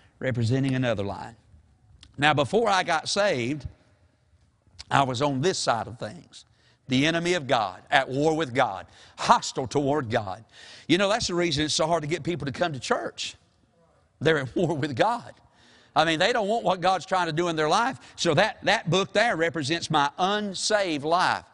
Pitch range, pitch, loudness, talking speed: 120-175 Hz, 150 Hz, -25 LUFS, 190 wpm